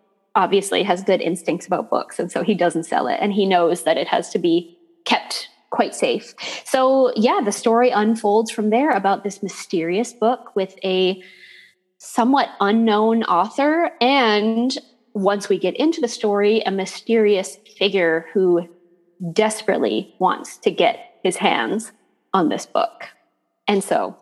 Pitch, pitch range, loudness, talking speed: 205 Hz, 190-235 Hz, -20 LUFS, 150 wpm